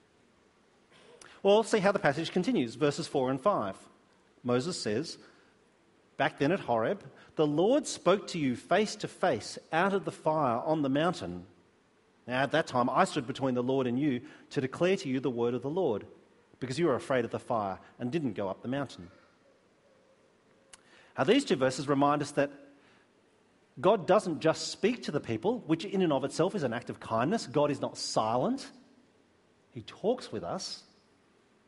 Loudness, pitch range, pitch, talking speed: -30 LUFS, 130-185 Hz, 145 Hz, 180 wpm